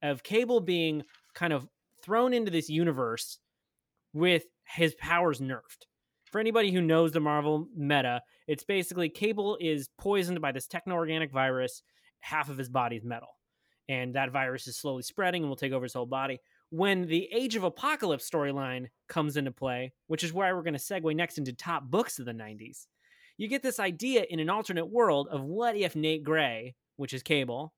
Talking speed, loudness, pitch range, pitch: 190 wpm, -30 LUFS, 135-180 Hz, 160 Hz